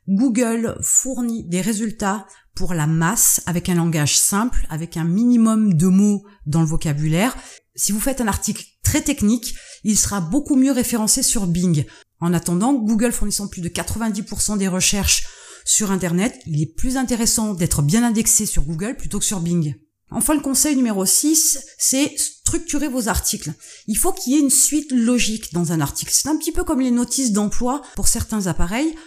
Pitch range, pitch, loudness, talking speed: 180-255 Hz, 215 Hz, -18 LUFS, 180 wpm